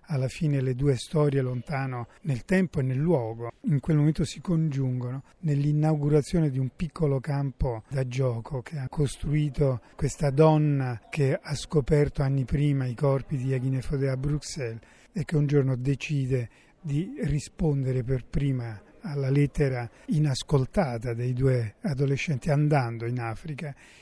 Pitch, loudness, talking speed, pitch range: 140 Hz, -27 LUFS, 140 wpm, 130-150 Hz